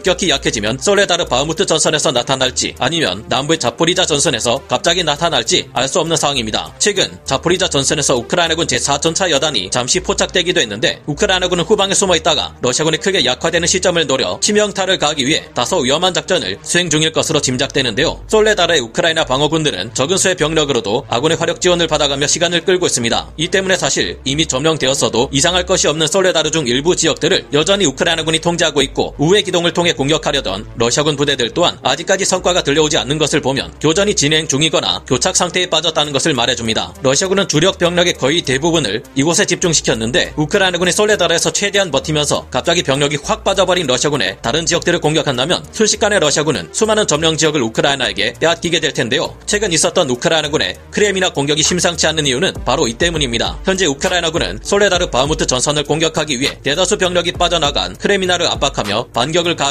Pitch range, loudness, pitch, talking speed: 145-180 Hz, -14 LUFS, 160 Hz, 490 characters per minute